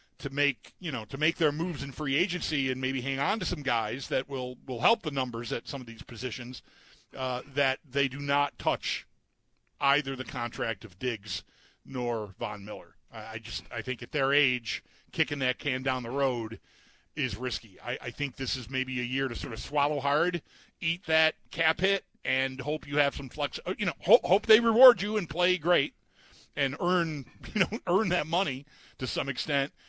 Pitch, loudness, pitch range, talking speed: 140 Hz, -29 LUFS, 125-160 Hz, 205 wpm